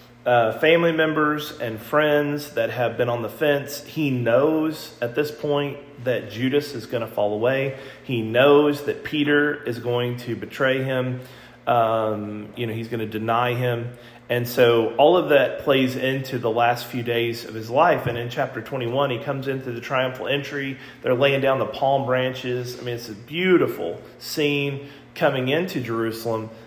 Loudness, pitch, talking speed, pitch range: -22 LUFS, 130 Hz, 180 wpm, 120-140 Hz